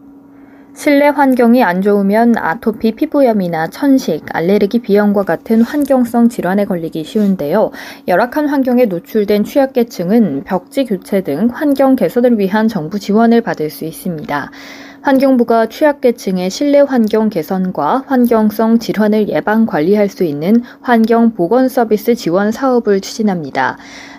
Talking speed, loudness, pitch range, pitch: 315 characters per minute, -13 LUFS, 195-250 Hz, 225 Hz